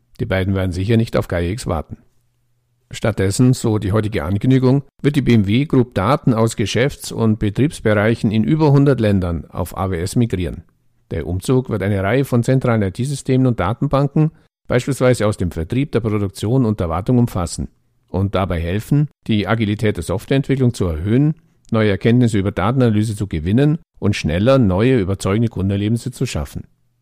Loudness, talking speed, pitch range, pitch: -18 LUFS, 160 wpm, 100-130 Hz, 115 Hz